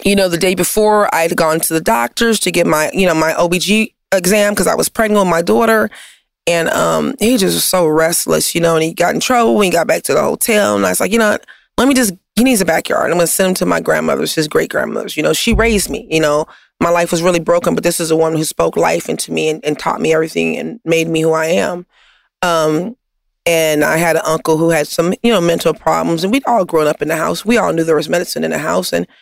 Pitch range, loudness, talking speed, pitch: 160-205 Hz, -14 LUFS, 275 wpm, 170 Hz